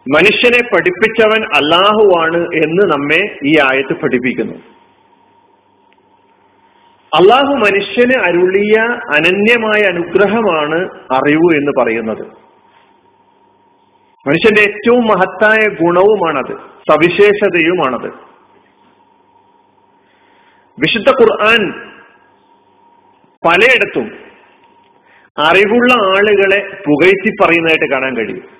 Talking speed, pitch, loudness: 65 wpm, 225 Hz, -10 LUFS